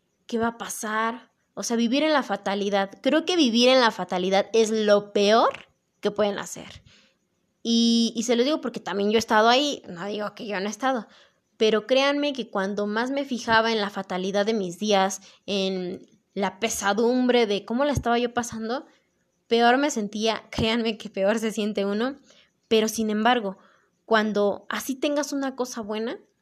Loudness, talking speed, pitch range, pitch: -24 LUFS, 180 wpm, 200-240 Hz, 225 Hz